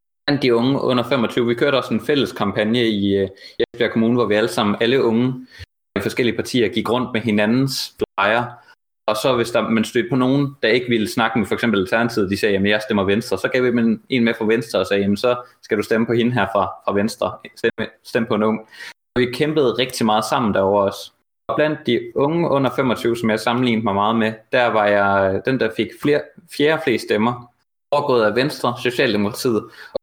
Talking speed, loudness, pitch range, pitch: 220 wpm, -19 LUFS, 105-125 Hz, 115 Hz